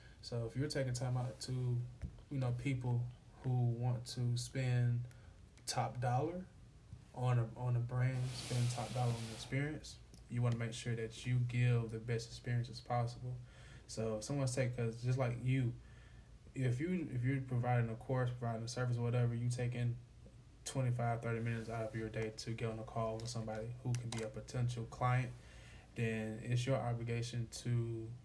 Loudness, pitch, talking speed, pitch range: -40 LUFS, 120 Hz, 180 wpm, 115-125 Hz